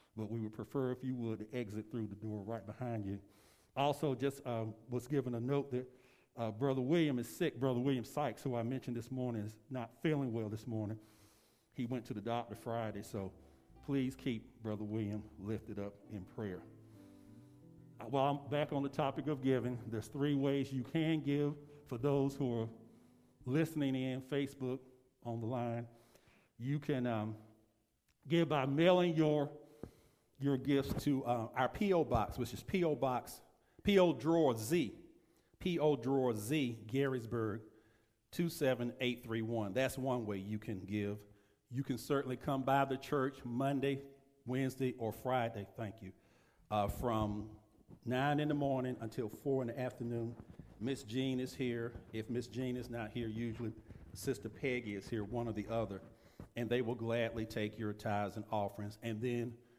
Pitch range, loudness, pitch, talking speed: 110-135 Hz, -38 LUFS, 120 Hz, 170 wpm